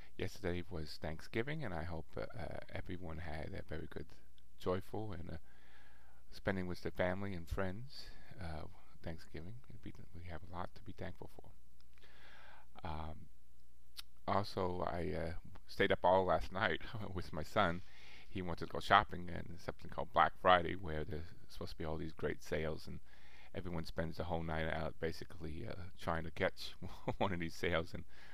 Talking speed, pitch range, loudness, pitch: 170 wpm, 75-95 Hz, -40 LUFS, 85 Hz